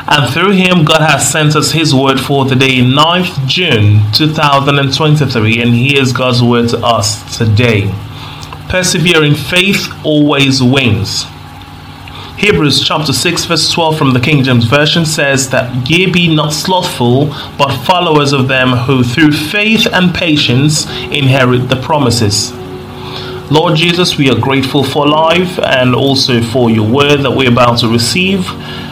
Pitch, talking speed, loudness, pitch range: 140 Hz, 145 wpm, -9 LUFS, 125-155 Hz